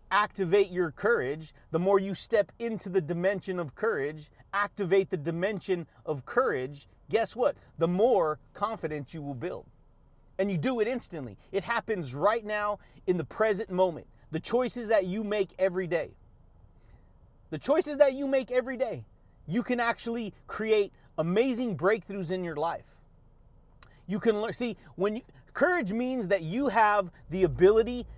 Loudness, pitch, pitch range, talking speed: -29 LUFS, 190 Hz, 155-220 Hz, 155 wpm